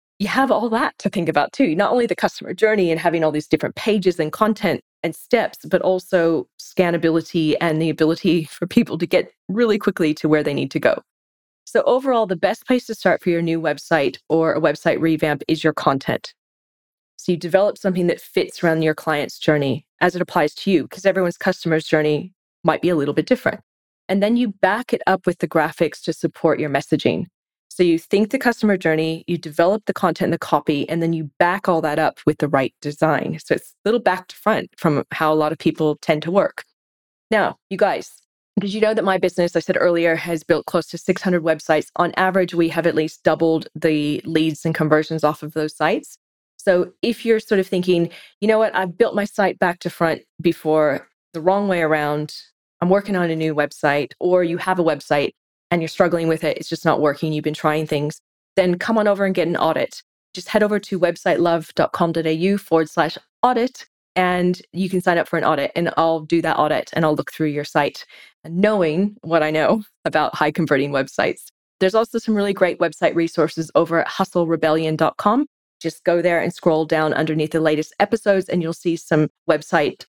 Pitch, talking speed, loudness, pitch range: 170 Hz, 215 wpm, -20 LUFS, 155-190 Hz